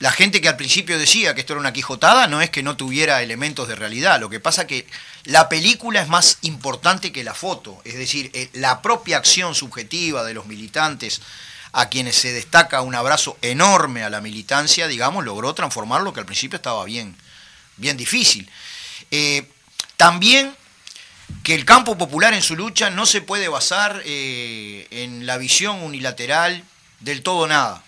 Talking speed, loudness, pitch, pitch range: 180 wpm, -17 LUFS, 145 Hz, 125-175 Hz